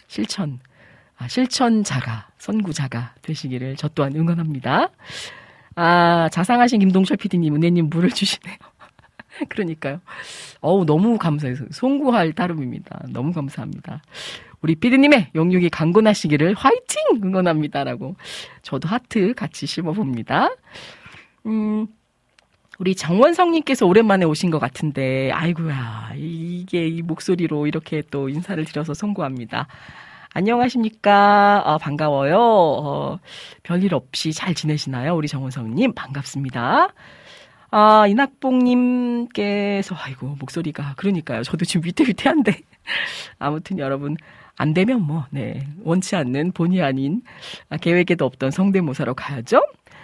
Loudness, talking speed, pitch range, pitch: -20 LUFS, 295 characters per minute, 145-205 Hz, 170 Hz